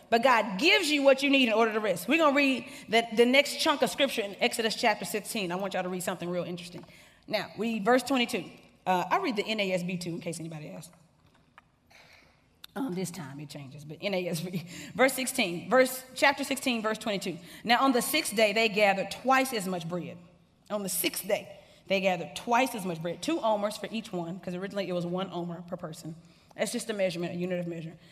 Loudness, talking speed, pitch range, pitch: -28 LUFS, 220 wpm, 175-240 Hz, 200 Hz